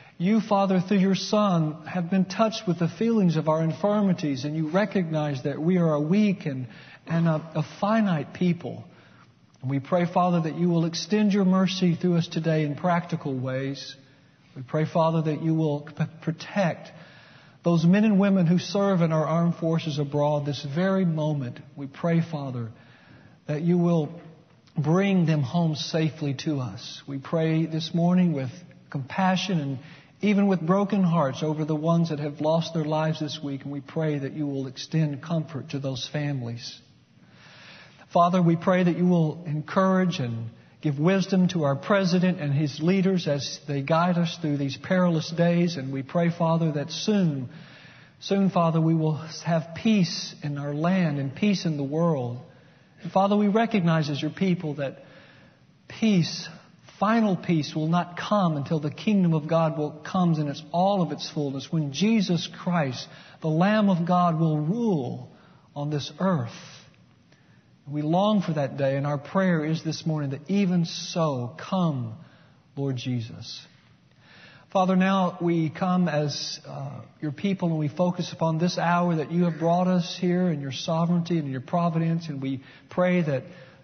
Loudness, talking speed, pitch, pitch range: -25 LUFS, 170 wpm, 165 Hz, 145-180 Hz